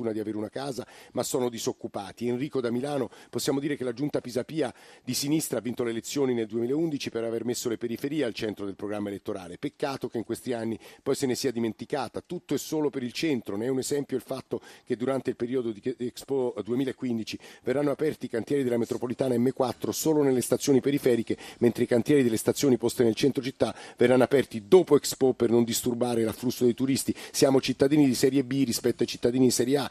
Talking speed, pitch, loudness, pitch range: 210 wpm, 125 Hz, -27 LUFS, 115-135 Hz